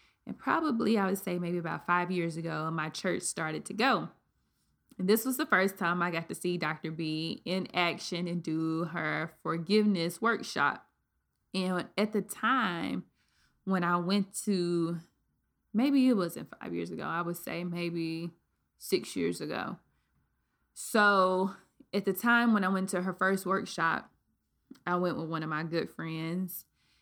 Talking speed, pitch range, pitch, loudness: 165 wpm, 165-200 Hz, 180 Hz, -31 LUFS